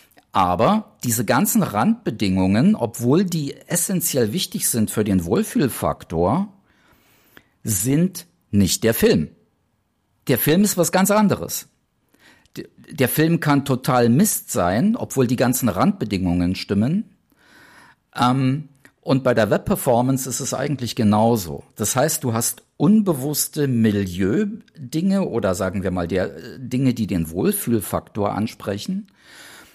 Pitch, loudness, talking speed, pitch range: 130 Hz, -20 LUFS, 115 wpm, 110-175 Hz